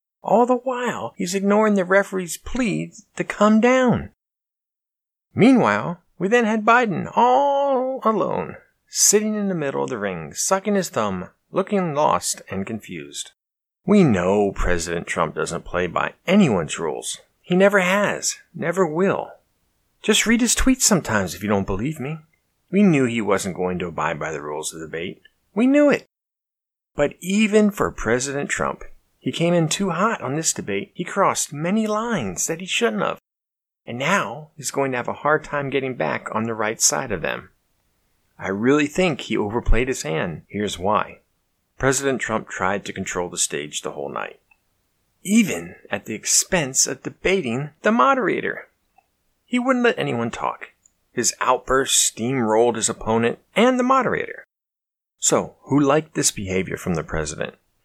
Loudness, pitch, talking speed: -21 LUFS, 170 Hz, 165 wpm